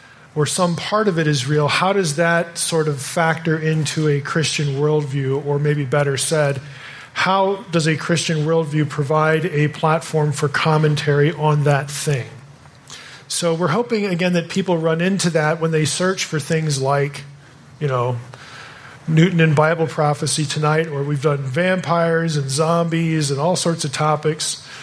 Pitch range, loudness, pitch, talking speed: 145-165 Hz, -18 LUFS, 155 Hz, 160 wpm